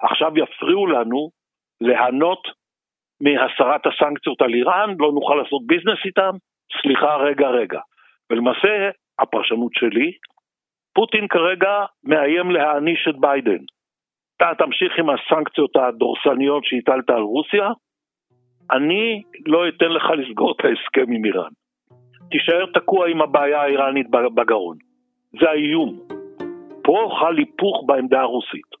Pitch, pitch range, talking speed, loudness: 160 Hz, 140-215 Hz, 115 wpm, -18 LUFS